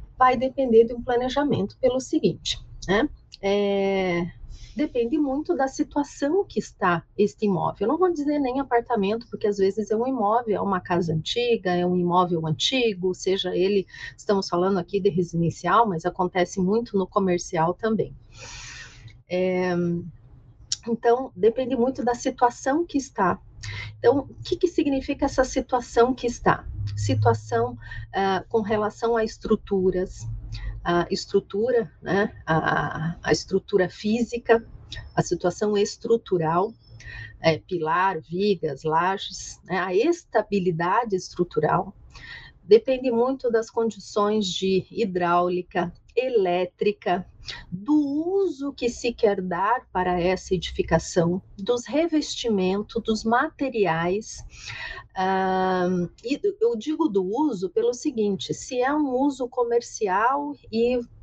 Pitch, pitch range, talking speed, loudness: 205 Hz, 180-245 Hz, 125 wpm, -24 LUFS